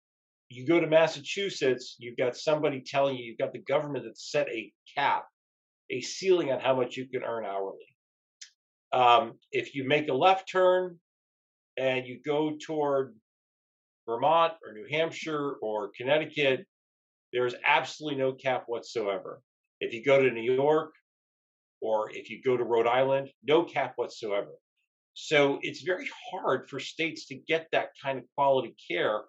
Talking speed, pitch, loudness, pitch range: 160 wpm, 135 Hz, -28 LUFS, 120-155 Hz